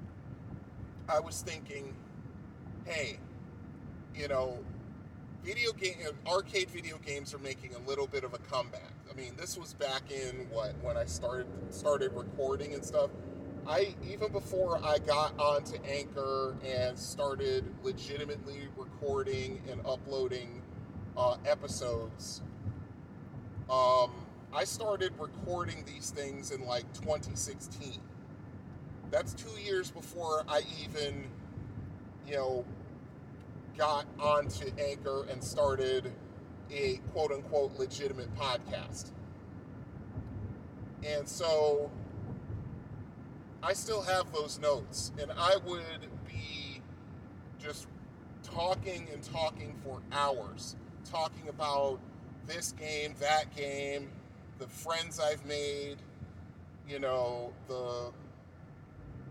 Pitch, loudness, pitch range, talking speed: 135 Hz, -36 LUFS, 120-150 Hz, 105 wpm